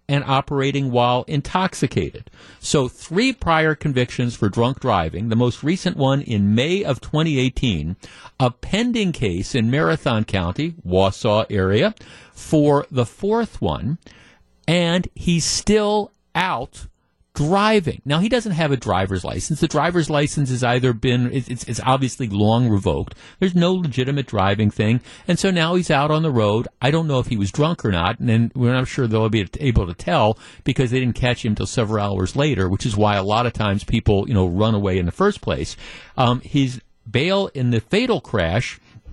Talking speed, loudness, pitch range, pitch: 180 wpm, -20 LUFS, 110-155 Hz, 125 Hz